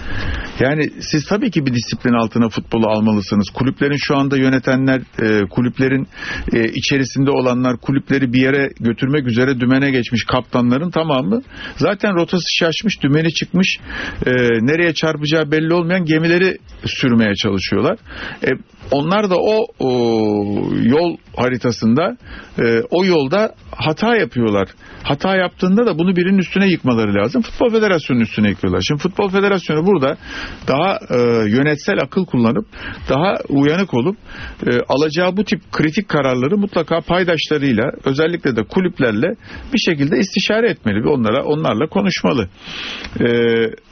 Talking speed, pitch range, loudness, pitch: 125 wpm, 120-180 Hz, -16 LUFS, 140 Hz